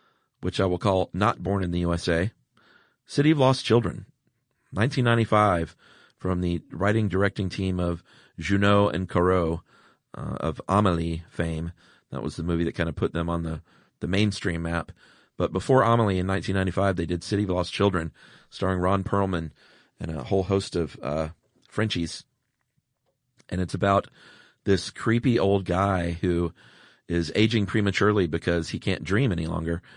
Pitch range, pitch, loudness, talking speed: 85-105 Hz, 95 Hz, -25 LUFS, 155 wpm